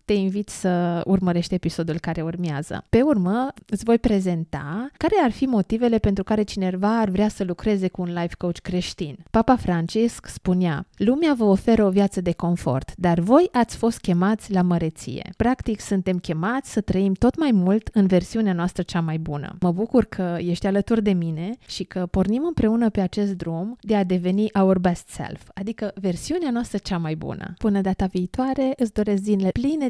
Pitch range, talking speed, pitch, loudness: 180-225 Hz, 185 wpm, 195 Hz, -22 LUFS